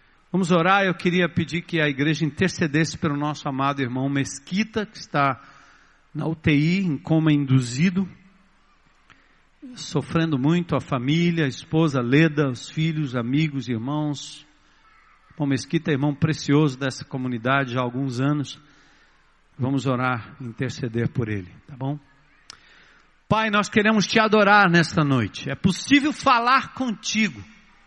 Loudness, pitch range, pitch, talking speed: -22 LUFS, 140-180 Hz, 150 Hz, 135 wpm